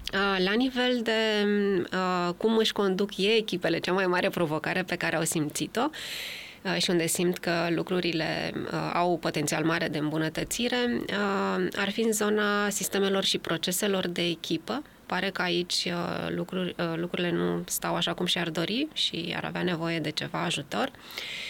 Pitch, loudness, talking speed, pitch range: 180 Hz, -28 LUFS, 165 wpm, 165-200 Hz